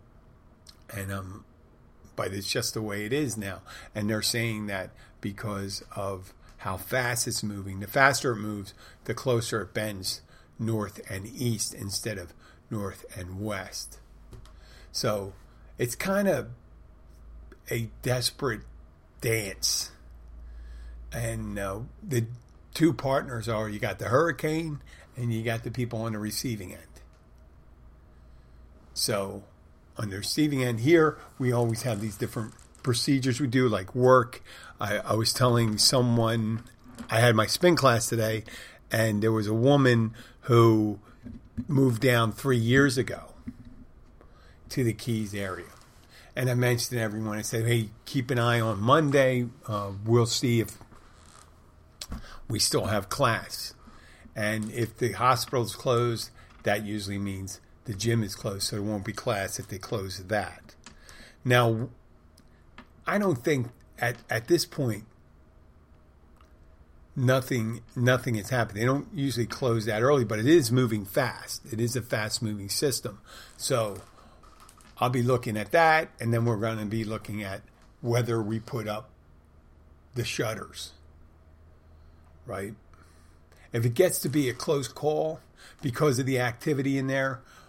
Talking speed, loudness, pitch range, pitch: 145 wpm, -27 LUFS, 95-125 Hz, 110 Hz